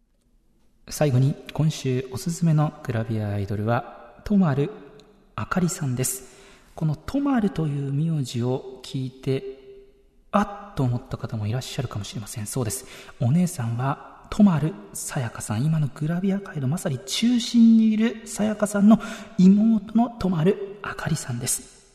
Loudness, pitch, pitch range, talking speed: -24 LUFS, 150 Hz, 130-200 Hz, 315 characters per minute